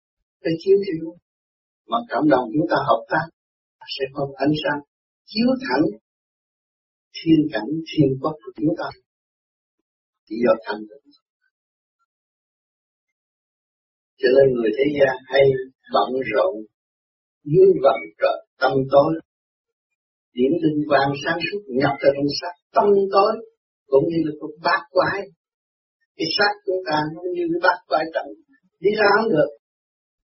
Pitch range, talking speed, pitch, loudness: 130-195 Hz, 140 wpm, 150 Hz, -20 LUFS